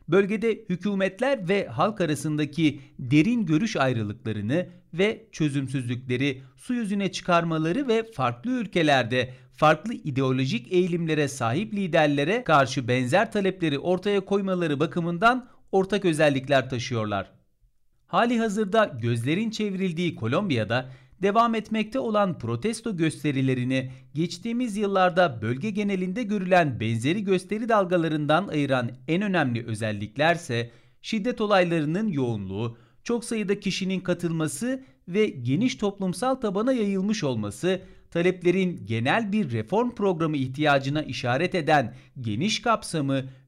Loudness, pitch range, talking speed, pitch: -25 LUFS, 135-205 Hz, 105 wpm, 170 Hz